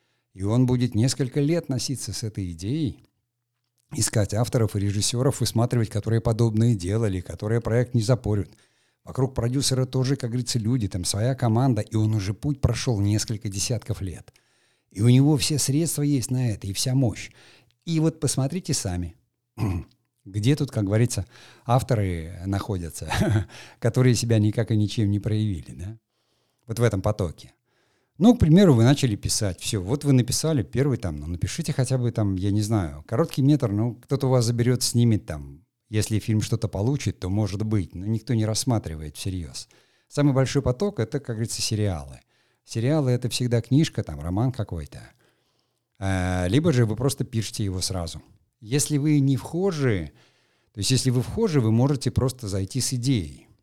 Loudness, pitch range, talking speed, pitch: -24 LUFS, 105-130 Hz, 165 wpm, 115 Hz